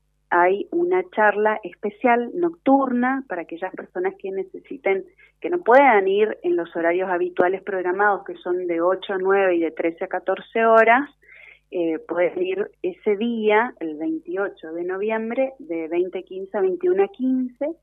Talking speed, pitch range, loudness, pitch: 160 wpm, 180-290 Hz, -22 LUFS, 210 Hz